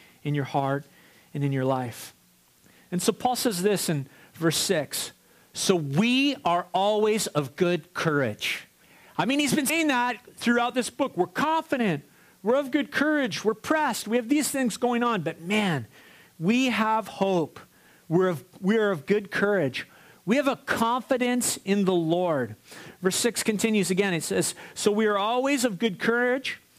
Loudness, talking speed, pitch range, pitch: -25 LUFS, 170 wpm, 170-245 Hz, 205 Hz